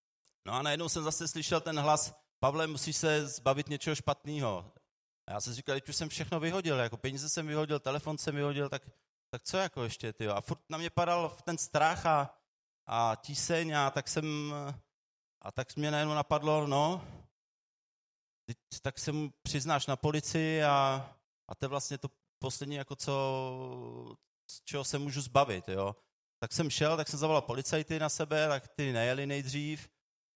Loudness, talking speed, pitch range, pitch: -33 LUFS, 175 wpm, 135-155 Hz, 145 Hz